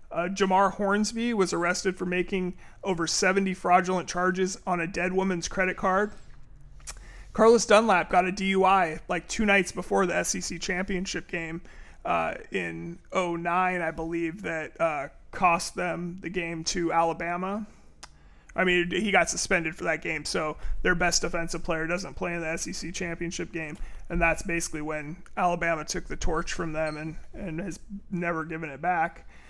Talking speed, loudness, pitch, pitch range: 165 wpm, -27 LUFS, 175 Hz, 165-190 Hz